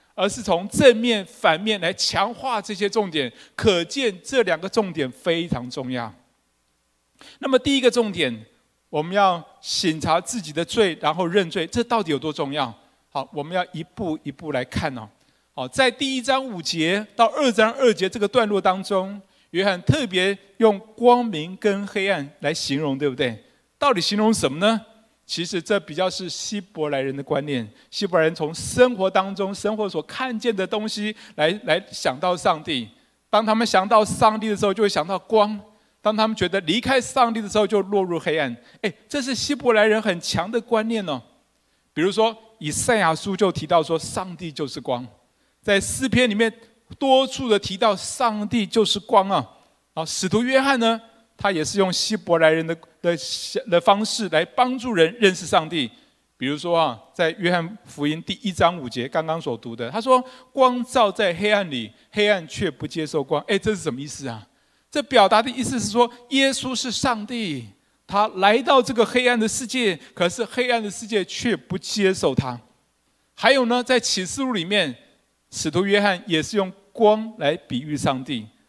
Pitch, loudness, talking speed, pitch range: 195 Hz, -22 LUFS, 260 characters per minute, 160-225 Hz